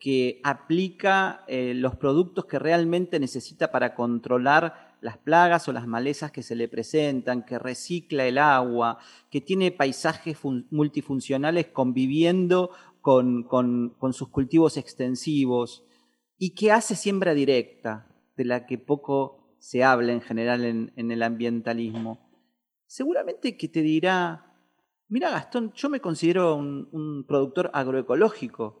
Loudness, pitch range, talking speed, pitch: -25 LUFS, 120-165 Hz, 135 wpm, 135 Hz